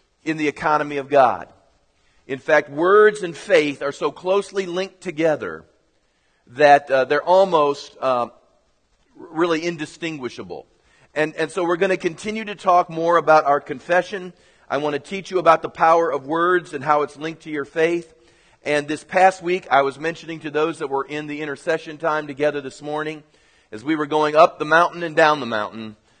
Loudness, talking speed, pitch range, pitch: -20 LUFS, 185 wpm, 145-175 Hz, 155 Hz